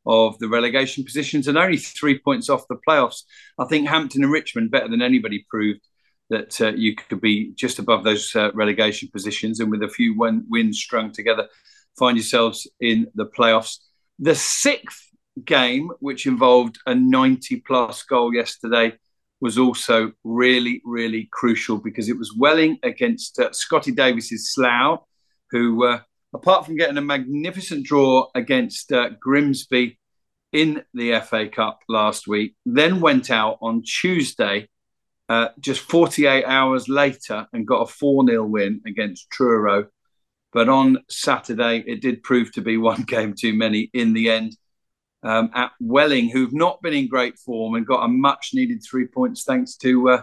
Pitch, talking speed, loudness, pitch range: 125 Hz, 165 wpm, -20 LUFS, 115-155 Hz